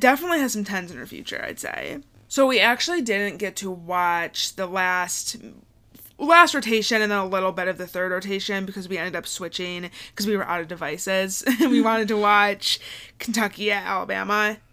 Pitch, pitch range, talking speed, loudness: 200 Hz, 185-220 Hz, 190 wpm, -22 LUFS